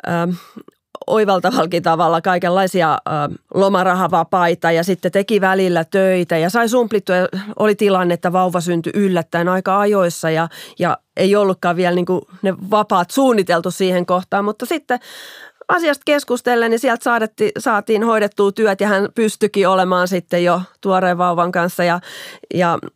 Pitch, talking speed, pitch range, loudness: 190 Hz, 140 wpm, 175-210 Hz, -16 LUFS